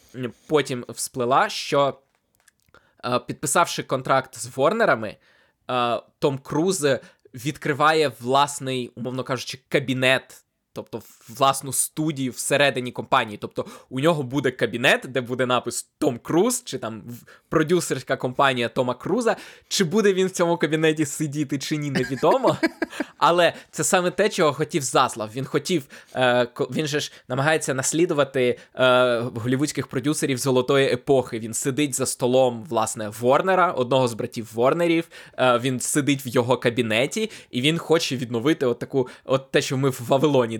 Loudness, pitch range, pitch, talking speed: -22 LUFS, 125-155 Hz, 135 Hz, 135 wpm